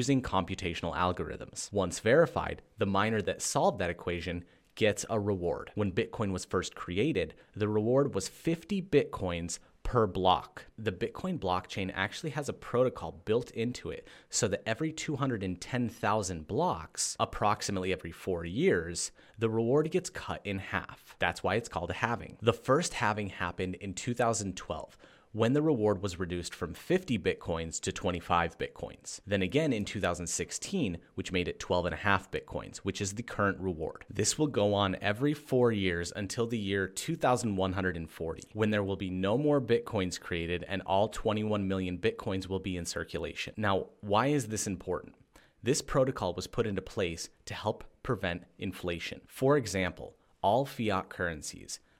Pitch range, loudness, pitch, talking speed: 90-115 Hz, -32 LUFS, 100 Hz, 155 wpm